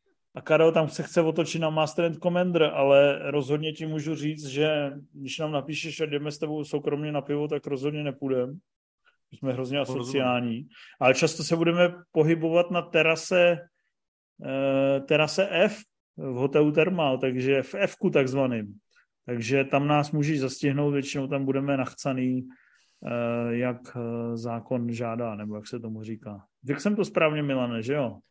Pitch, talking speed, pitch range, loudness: 145 Hz, 155 wpm, 130-160 Hz, -26 LUFS